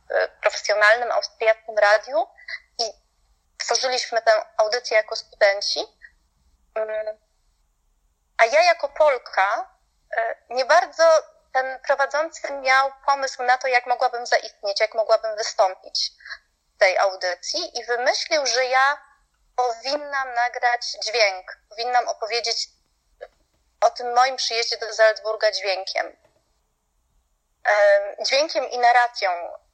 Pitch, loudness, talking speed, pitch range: 245 Hz, -21 LUFS, 100 wpm, 220-295 Hz